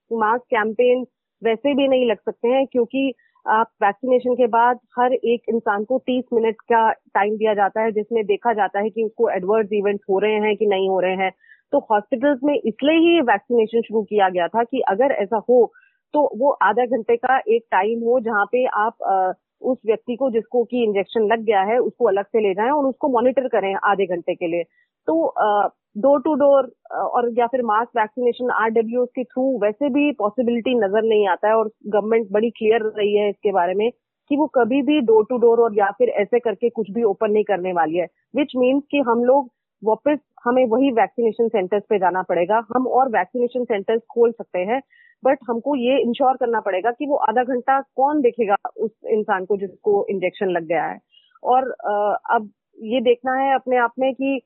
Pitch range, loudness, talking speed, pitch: 210-255 Hz, -20 LUFS, 200 wpm, 230 Hz